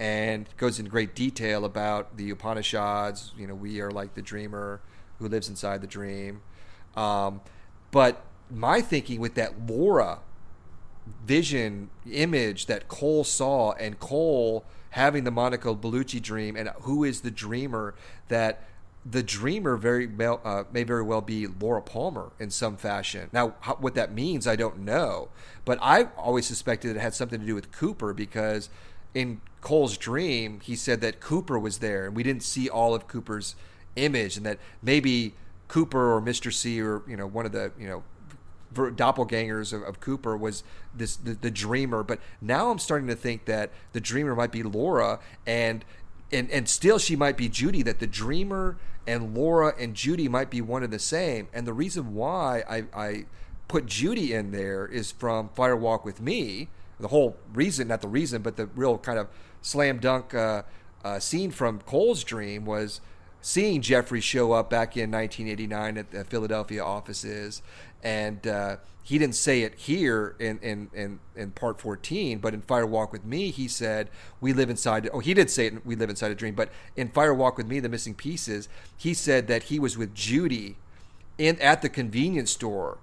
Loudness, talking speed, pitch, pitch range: -27 LUFS, 185 wpm, 110 Hz, 105-125 Hz